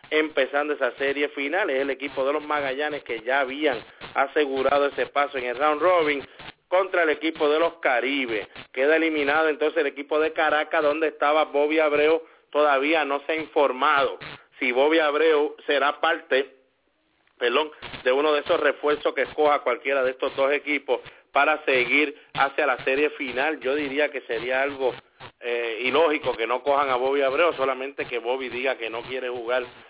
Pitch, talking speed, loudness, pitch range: 145 Hz, 175 wpm, -23 LUFS, 135-155 Hz